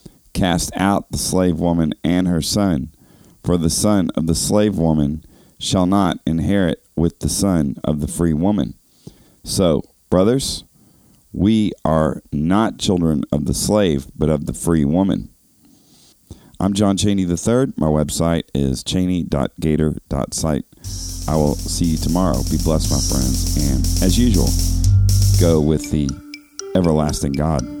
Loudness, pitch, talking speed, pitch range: -18 LUFS, 85 Hz, 140 wpm, 80-95 Hz